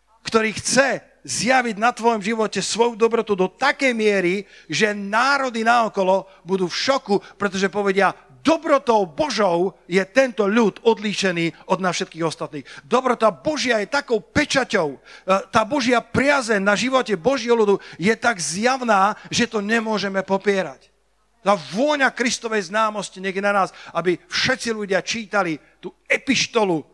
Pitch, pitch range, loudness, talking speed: 215 Hz, 190-240 Hz, -20 LUFS, 135 wpm